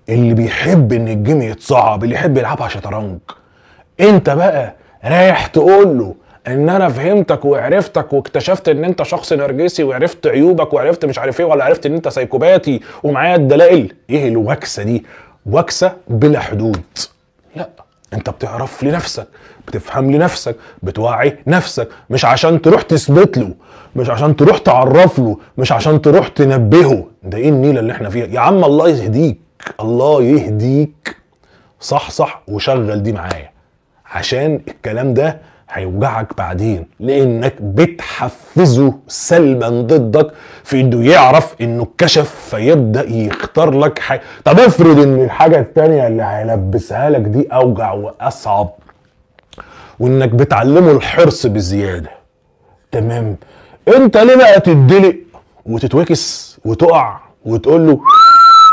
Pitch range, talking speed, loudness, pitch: 115-160 Hz, 125 wpm, -11 LUFS, 135 Hz